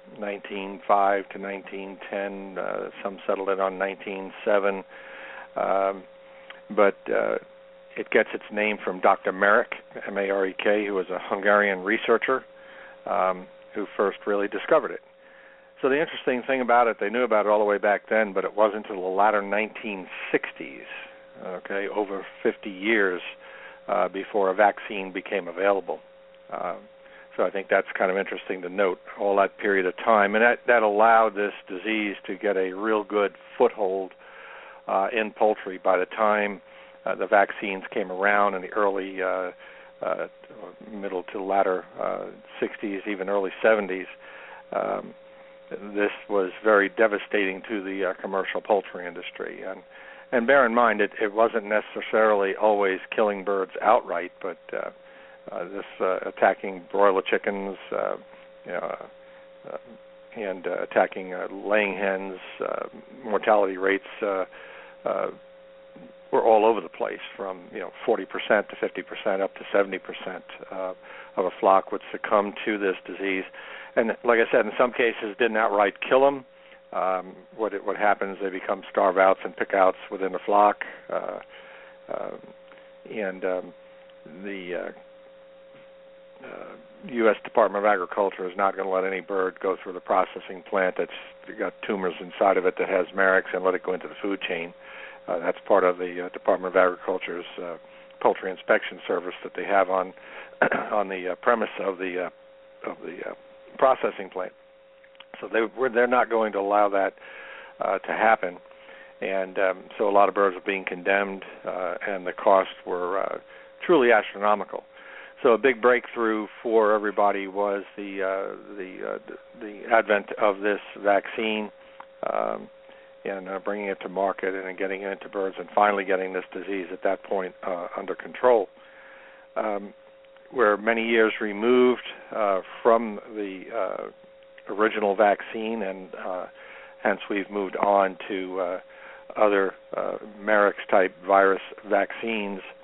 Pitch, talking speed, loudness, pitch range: 100 Hz, 160 wpm, -25 LUFS, 95-115 Hz